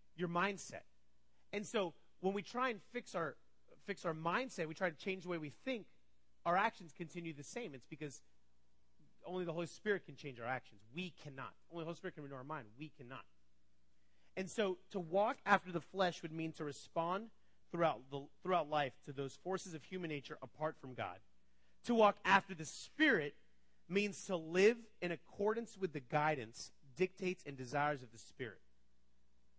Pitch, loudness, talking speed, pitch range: 160 Hz, -40 LUFS, 185 wpm, 125-185 Hz